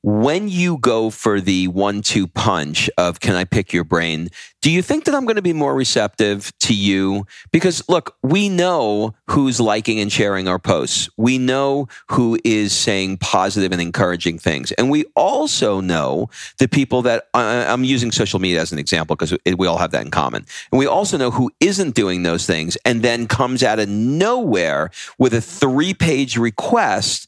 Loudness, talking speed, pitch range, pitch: -17 LUFS, 190 wpm, 100-135 Hz, 115 Hz